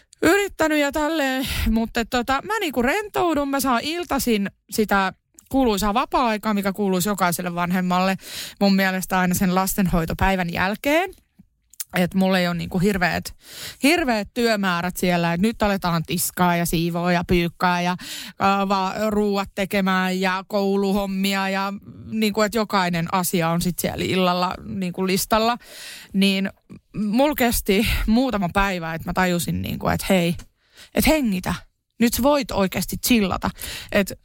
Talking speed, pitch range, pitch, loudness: 135 wpm, 180-230 Hz, 195 Hz, -21 LUFS